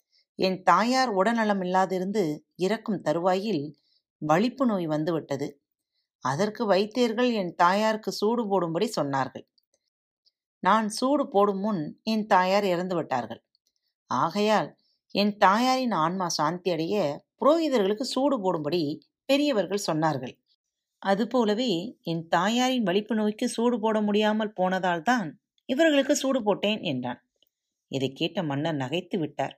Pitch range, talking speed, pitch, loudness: 170-230 Hz, 105 wpm, 200 Hz, -26 LUFS